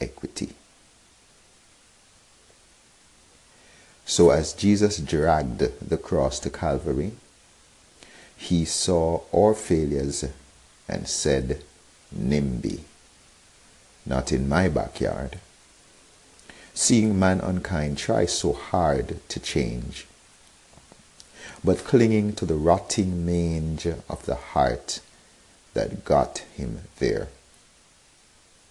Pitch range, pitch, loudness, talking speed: 70-95 Hz, 80 Hz, -24 LUFS, 85 wpm